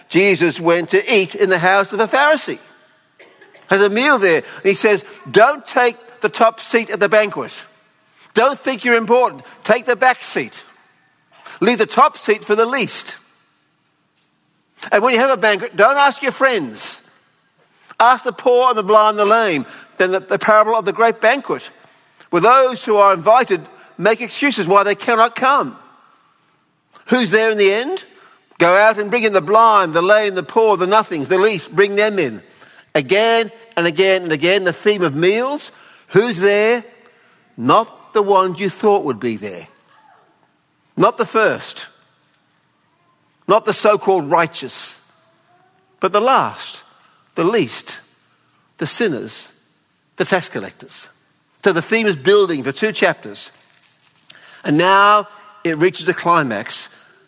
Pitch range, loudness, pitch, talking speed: 195-240 Hz, -15 LUFS, 215 Hz, 160 wpm